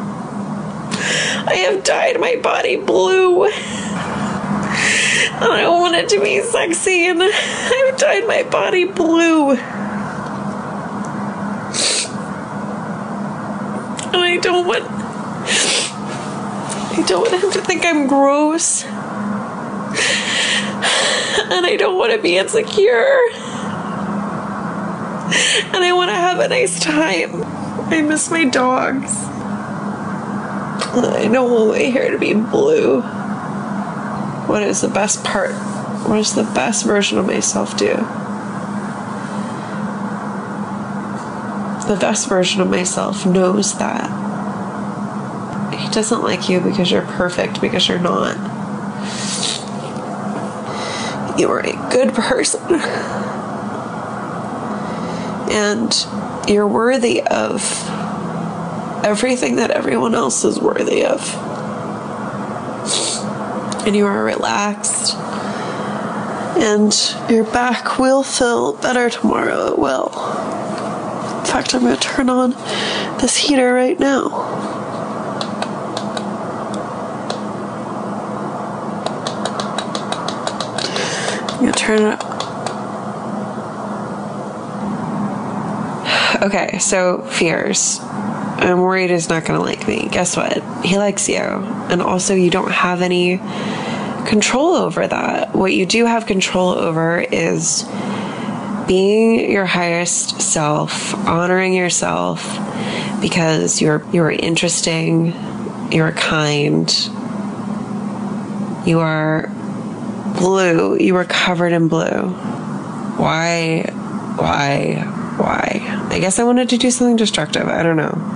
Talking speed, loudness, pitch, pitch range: 100 wpm, -17 LUFS, 215 Hz, 195-240 Hz